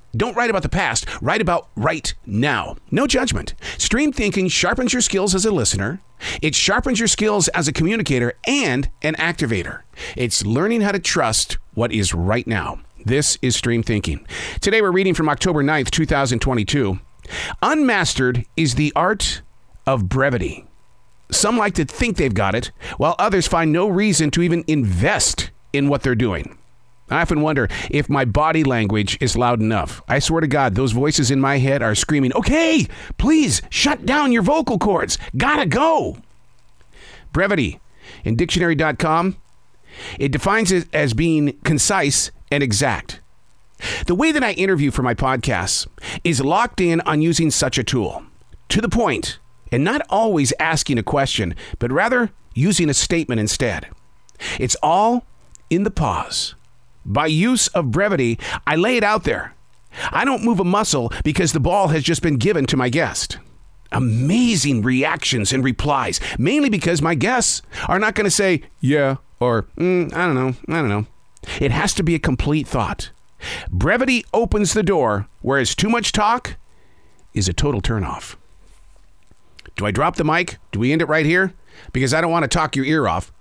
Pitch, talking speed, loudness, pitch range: 145 Hz, 170 wpm, -18 LUFS, 120-180 Hz